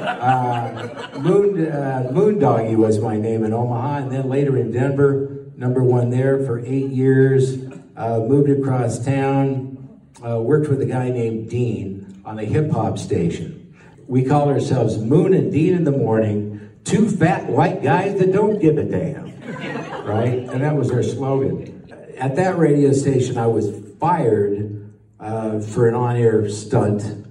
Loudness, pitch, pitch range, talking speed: -19 LUFS, 130 Hz, 115-140 Hz, 155 wpm